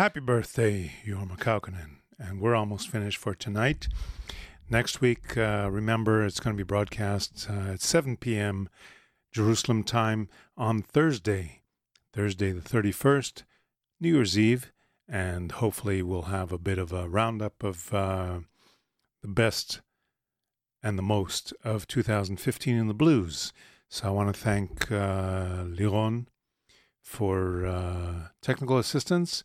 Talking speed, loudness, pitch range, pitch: 130 wpm, -29 LUFS, 95-115 Hz, 105 Hz